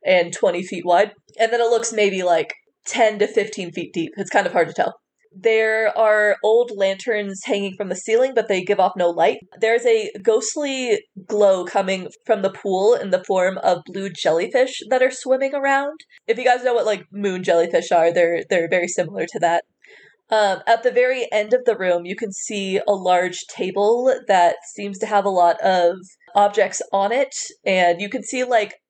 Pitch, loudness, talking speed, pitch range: 205 Hz, -19 LUFS, 200 wpm, 185-235 Hz